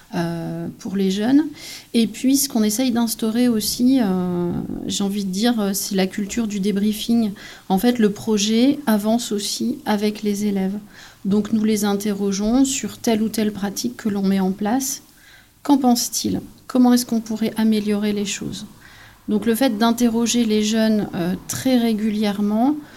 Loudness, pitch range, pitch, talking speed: -20 LUFS, 205-240 Hz, 215 Hz, 160 wpm